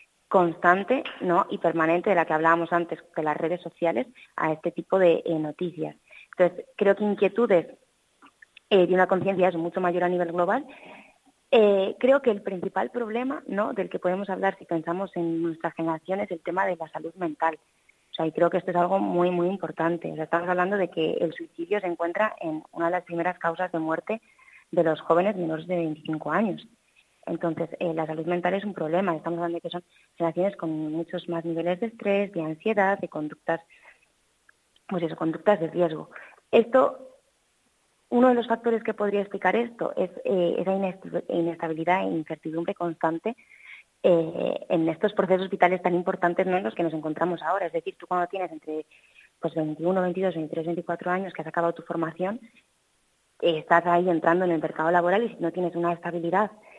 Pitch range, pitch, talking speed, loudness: 165-195 Hz, 175 Hz, 190 wpm, -26 LUFS